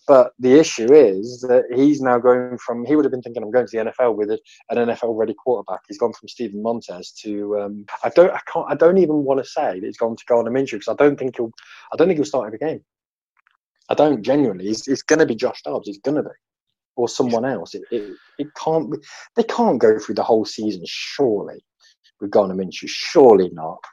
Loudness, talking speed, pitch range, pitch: -19 LUFS, 230 wpm, 110-145 Hz, 120 Hz